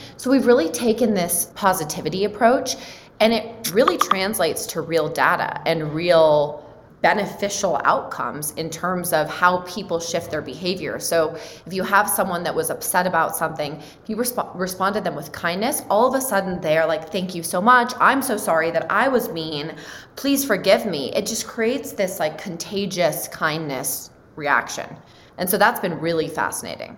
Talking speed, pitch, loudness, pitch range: 175 wpm, 180 Hz, -21 LUFS, 160-210 Hz